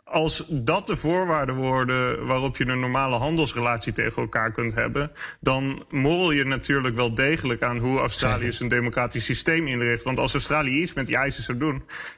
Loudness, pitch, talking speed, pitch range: -24 LUFS, 130 Hz, 175 wpm, 120-150 Hz